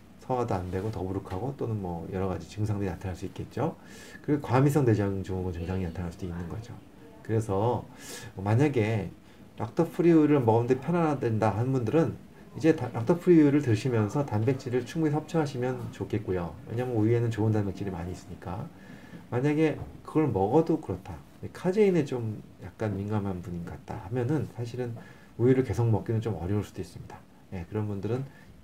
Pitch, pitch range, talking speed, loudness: 110 Hz, 95-130 Hz, 380 characters per minute, -28 LUFS